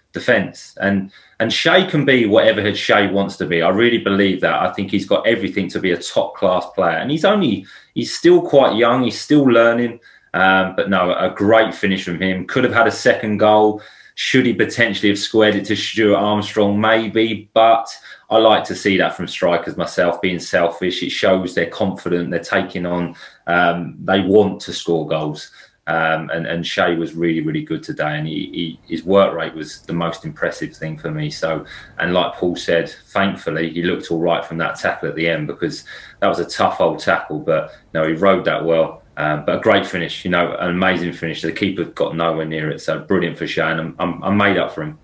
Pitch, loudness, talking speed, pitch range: 95 Hz, -17 LUFS, 220 wpm, 85-105 Hz